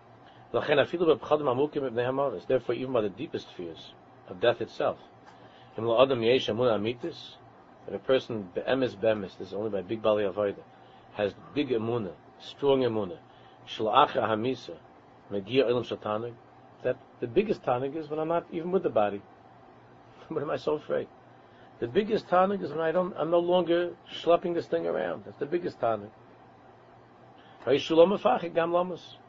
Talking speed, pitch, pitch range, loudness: 170 wpm, 130 Hz, 110-170 Hz, -28 LUFS